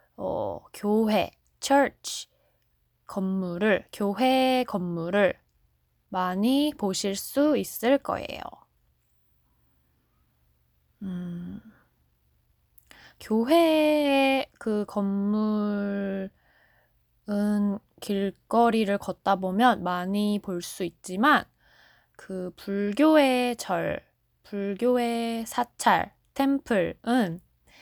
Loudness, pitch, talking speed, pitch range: -26 LUFS, 200 Hz, 135 characters per minute, 180-240 Hz